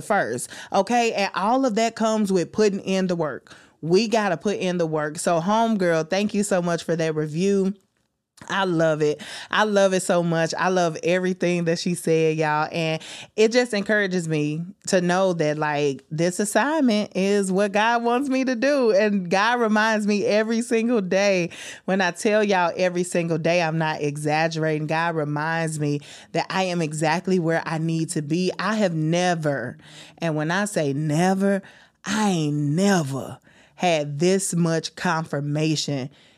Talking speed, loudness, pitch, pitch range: 175 wpm, -22 LUFS, 175 Hz, 160-205 Hz